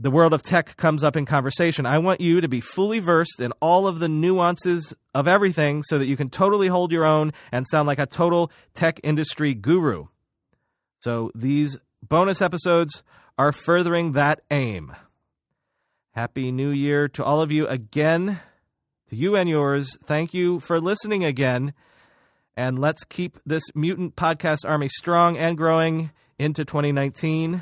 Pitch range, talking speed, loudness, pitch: 140-170 Hz, 165 wpm, -22 LUFS, 155 Hz